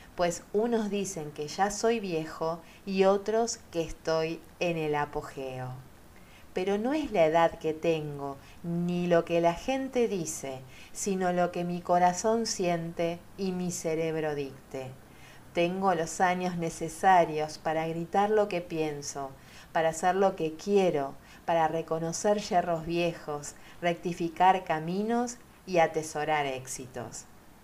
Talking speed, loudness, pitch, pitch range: 130 wpm, -29 LUFS, 170 Hz, 155-185 Hz